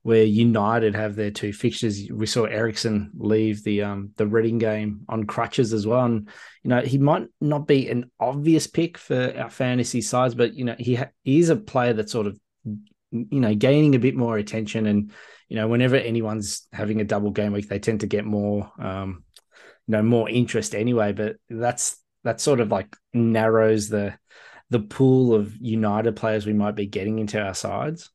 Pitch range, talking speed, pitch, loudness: 105-120 Hz, 195 wpm, 110 Hz, -23 LUFS